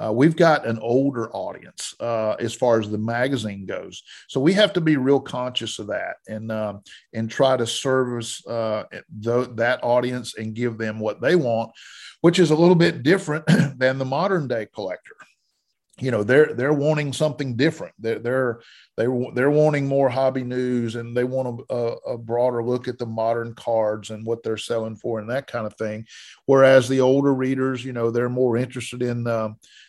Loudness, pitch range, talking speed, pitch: -22 LUFS, 115-135 Hz, 195 wpm, 125 Hz